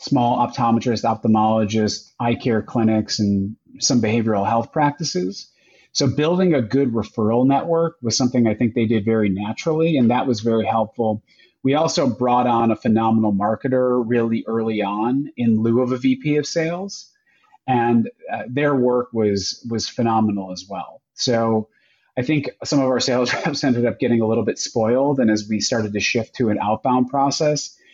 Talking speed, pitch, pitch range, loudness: 175 wpm, 120 Hz, 110-135 Hz, -20 LUFS